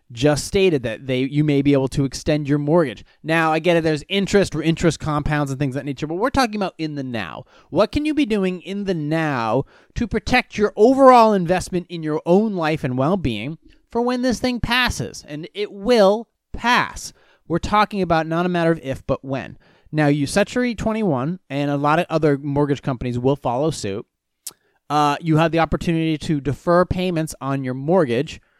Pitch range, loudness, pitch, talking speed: 145-190 Hz, -20 LUFS, 160 Hz, 200 wpm